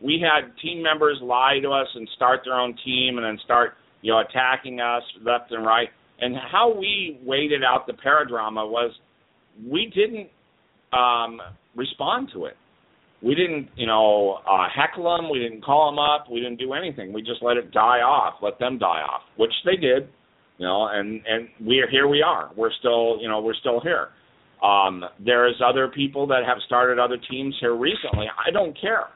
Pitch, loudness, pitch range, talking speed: 125 Hz, -22 LUFS, 115-145 Hz, 195 wpm